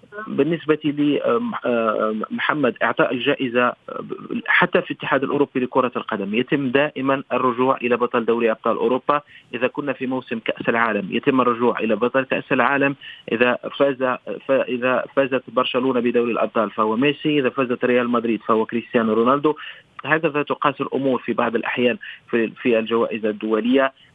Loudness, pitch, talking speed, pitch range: -20 LUFS, 125 Hz, 135 wpm, 120-140 Hz